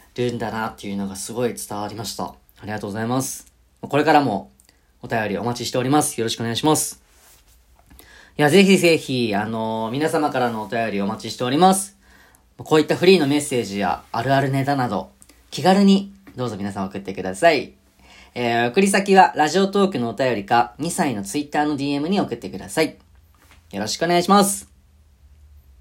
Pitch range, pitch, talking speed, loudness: 100-150 Hz, 120 Hz, 390 characters per minute, -20 LUFS